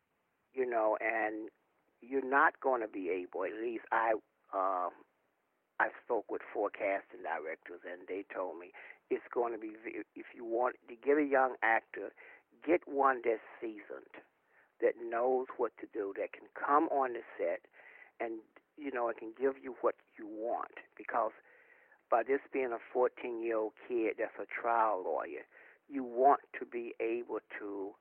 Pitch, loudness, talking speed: 360 Hz, -35 LUFS, 170 wpm